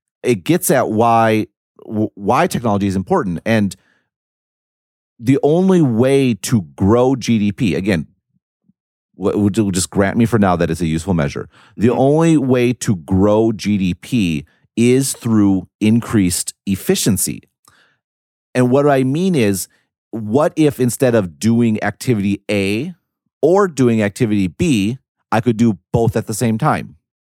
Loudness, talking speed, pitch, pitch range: -16 LUFS, 130 wpm, 115 Hz, 100-125 Hz